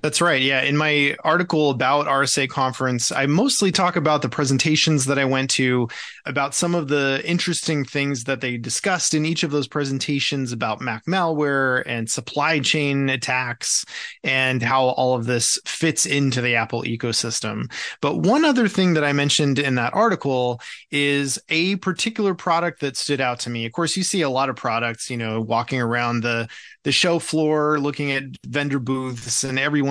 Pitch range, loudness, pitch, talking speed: 125-155 Hz, -20 LUFS, 140 Hz, 185 wpm